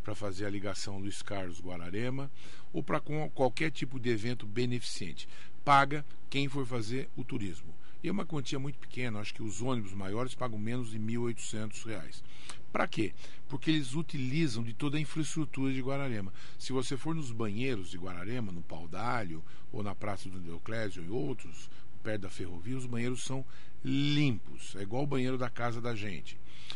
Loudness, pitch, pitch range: -36 LUFS, 125 Hz, 105-140 Hz